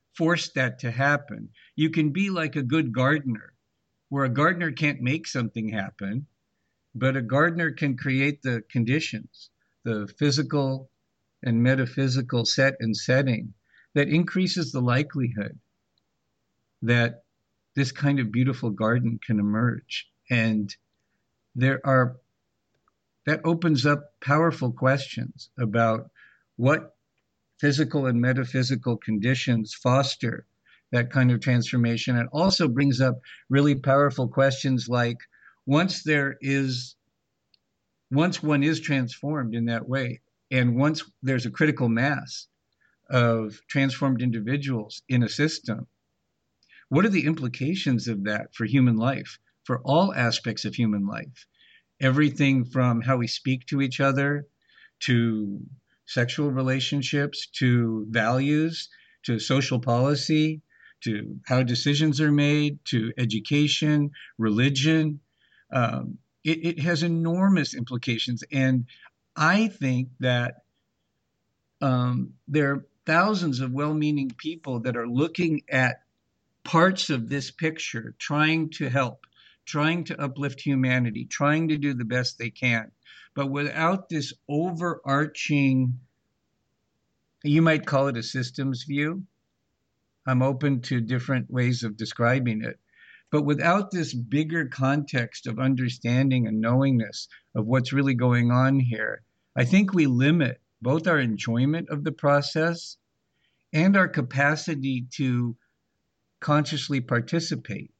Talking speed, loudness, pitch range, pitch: 125 wpm, -25 LUFS, 120-150 Hz, 135 Hz